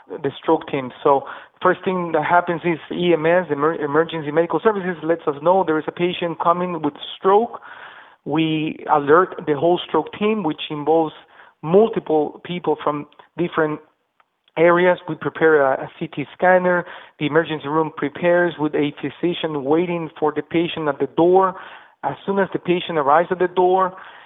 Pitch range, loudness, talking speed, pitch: 155-175 Hz, -19 LUFS, 165 wpm, 165 Hz